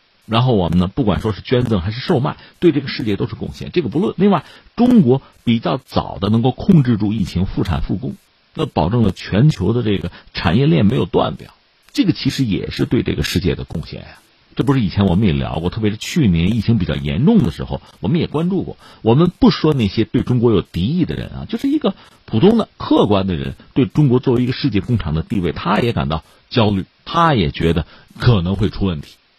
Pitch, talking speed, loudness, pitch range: 110 Hz, 335 characters per minute, -17 LUFS, 90-125 Hz